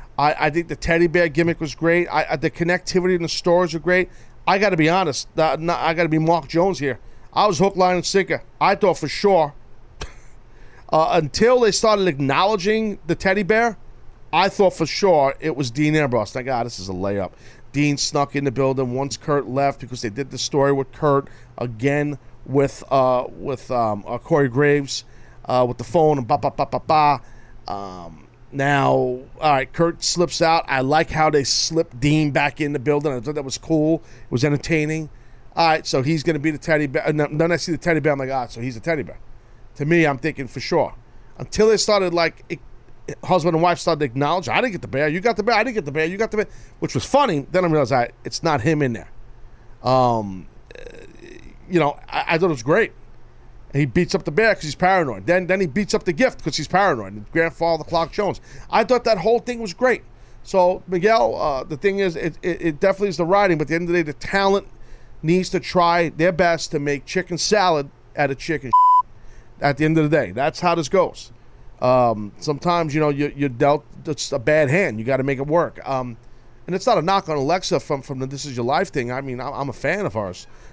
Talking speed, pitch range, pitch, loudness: 235 wpm, 135-175 Hz, 155 Hz, -20 LUFS